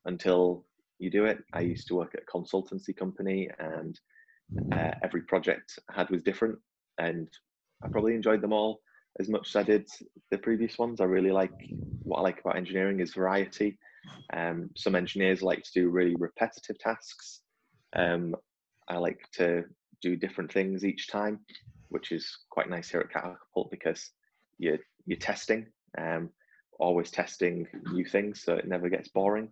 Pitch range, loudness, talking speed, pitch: 90-105 Hz, -31 LUFS, 170 wpm, 95 Hz